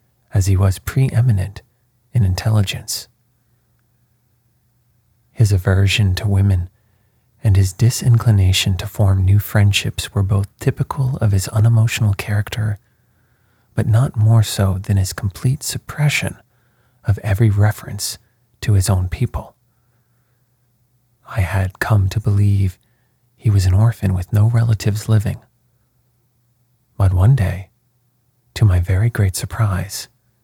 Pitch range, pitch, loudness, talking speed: 100-120 Hz, 115 Hz, -17 LUFS, 120 wpm